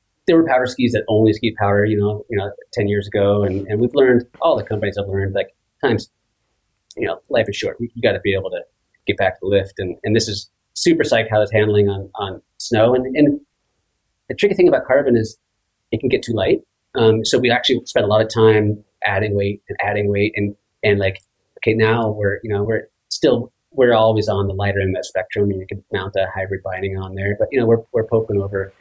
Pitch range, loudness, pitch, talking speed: 100-115 Hz, -18 LUFS, 105 Hz, 245 wpm